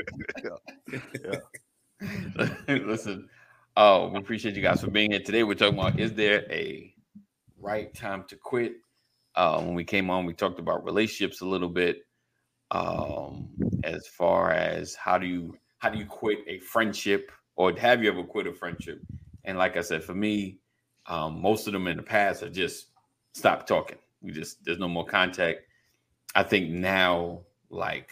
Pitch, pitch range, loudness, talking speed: 95 Hz, 90-105 Hz, -27 LUFS, 175 wpm